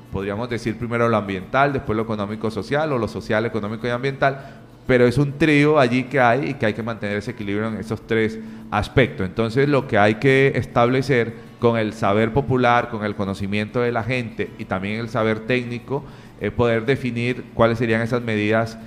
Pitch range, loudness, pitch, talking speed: 110-125 Hz, -21 LUFS, 115 Hz, 190 wpm